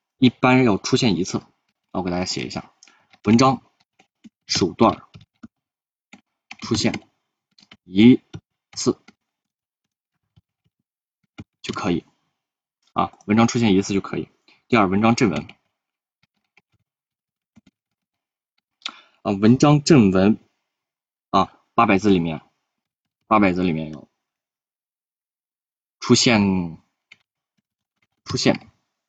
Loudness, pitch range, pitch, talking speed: -19 LUFS, 95-120 Hz, 105 Hz, 130 characters per minute